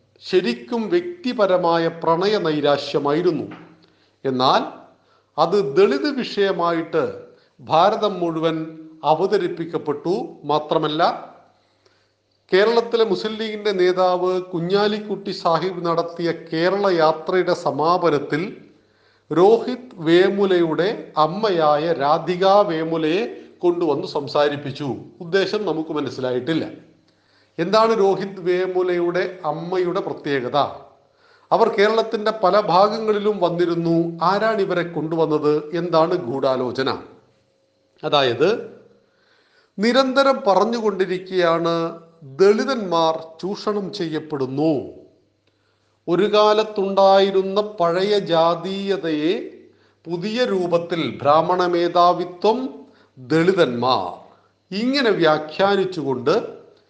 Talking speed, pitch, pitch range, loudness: 65 wpm, 180 Hz, 160-210 Hz, -20 LUFS